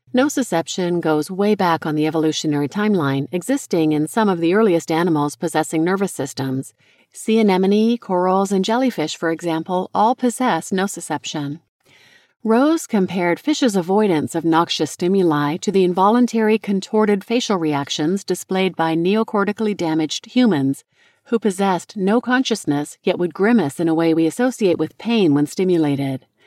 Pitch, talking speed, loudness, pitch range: 180 Hz, 140 wpm, -19 LUFS, 160-210 Hz